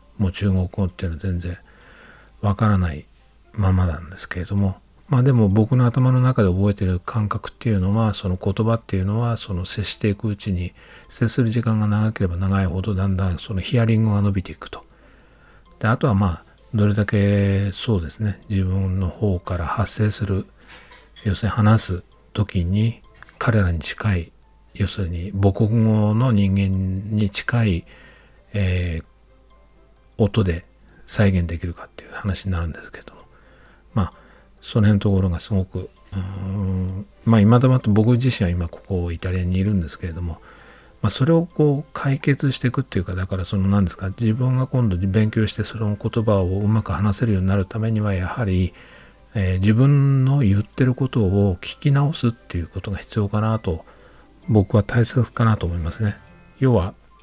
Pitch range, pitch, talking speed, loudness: 95-110 Hz, 100 Hz, 340 characters per minute, -21 LUFS